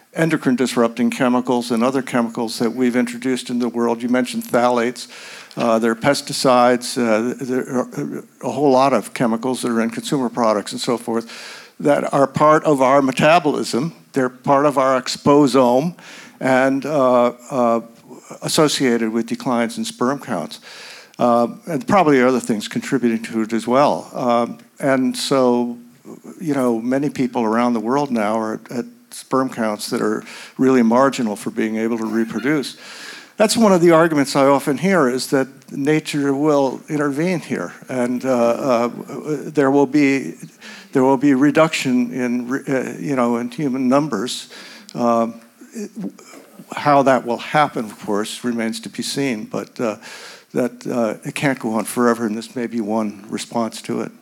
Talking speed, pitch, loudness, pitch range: 165 wpm, 125 Hz, -18 LUFS, 120-140 Hz